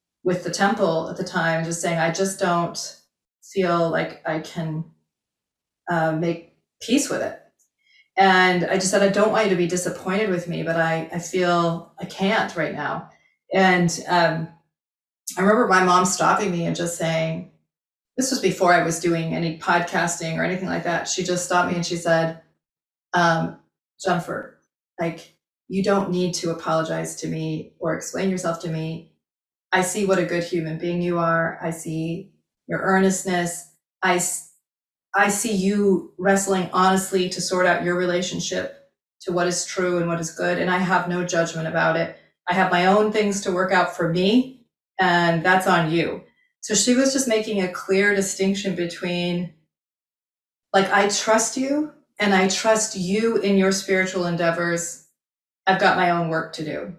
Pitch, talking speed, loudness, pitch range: 180 Hz, 175 wpm, -21 LUFS, 170-195 Hz